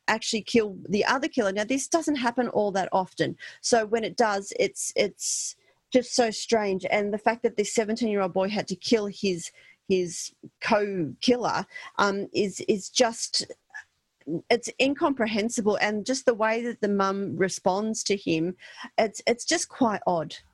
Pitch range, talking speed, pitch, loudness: 195-240 Hz, 170 wpm, 220 Hz, -26 LUFS